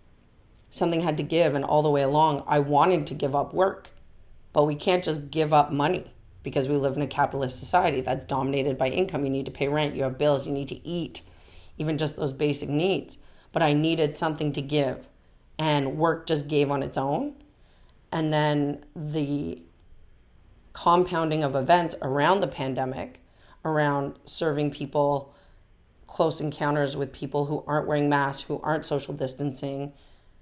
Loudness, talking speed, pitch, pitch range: -26 LUFS, 170 wpm, 145 Hz, 135-155 Hz